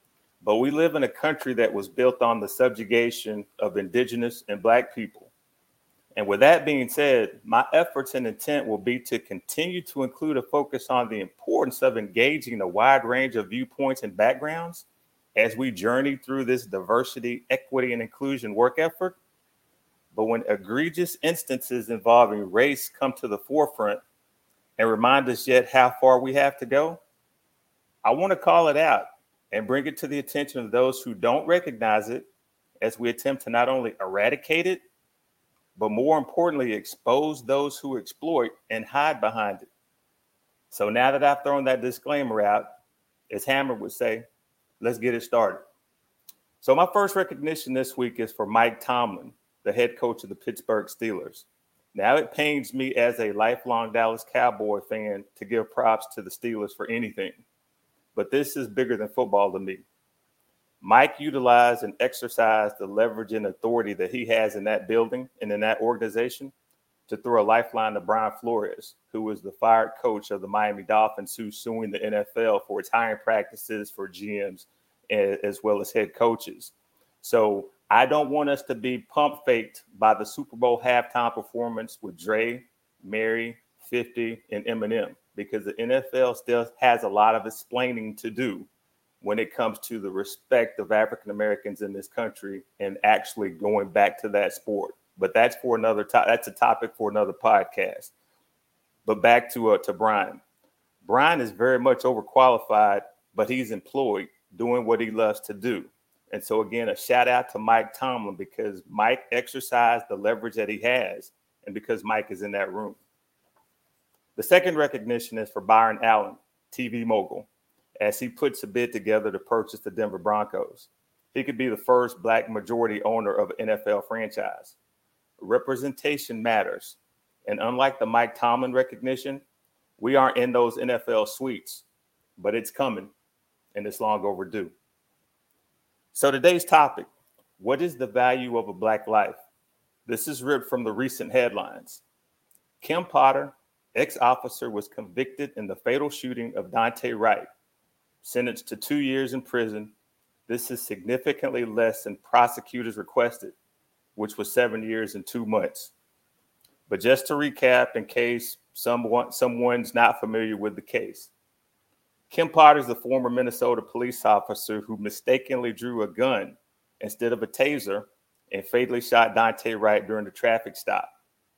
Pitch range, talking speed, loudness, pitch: 110-135 Hz, 165 wpm, -25 LUFS, 120 Hz